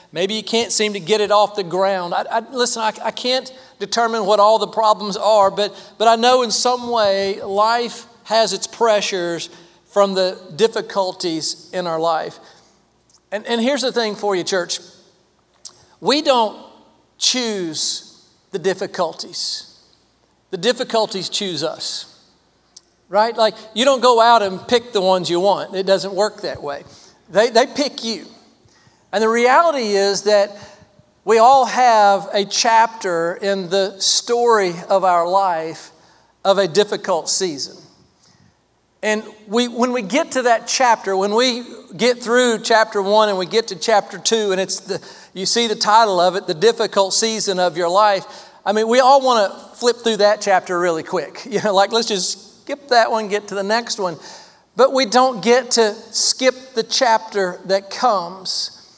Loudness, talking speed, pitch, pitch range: -17 LUFS, 170 wpm, 210 Hz, 195-235 Hz